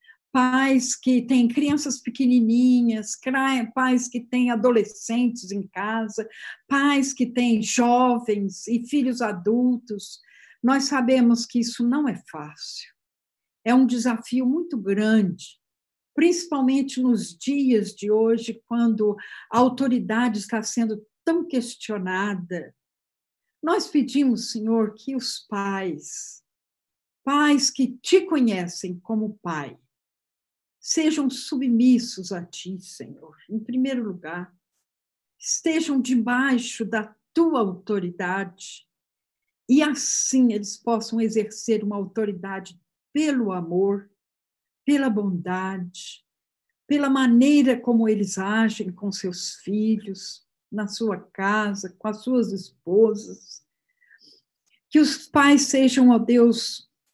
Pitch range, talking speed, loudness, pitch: 205-260 Hz, 105 wpm, -22 LUFS, 230 Hz